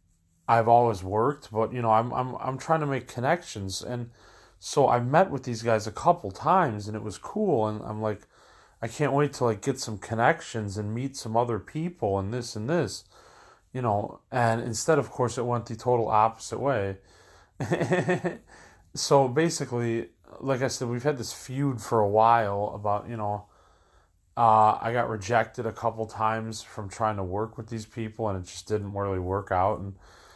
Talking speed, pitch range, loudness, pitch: 190 wpm, 105-130 Hz, -27 LUFS, 115 Hz